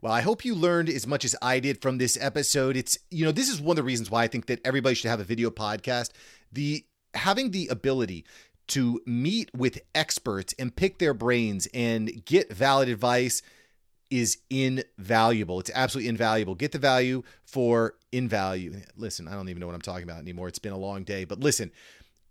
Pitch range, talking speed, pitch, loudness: 110-135 Hz, 205 wpm, 120 Hz, -27 LUFS